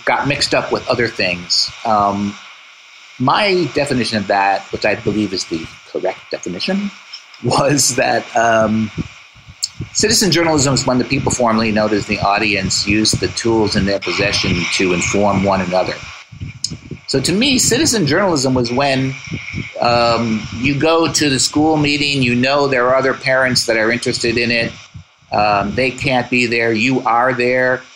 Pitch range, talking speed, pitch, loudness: 105-140 Hz, 160 wpm, 125 Hz, -15 LUFS